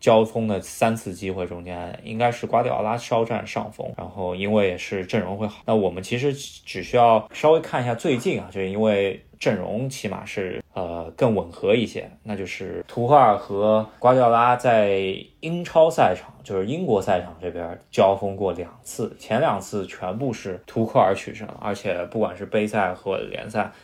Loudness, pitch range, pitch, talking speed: -23 LUFS, 95-120 Hz, 110 Hz, 275 characters per minute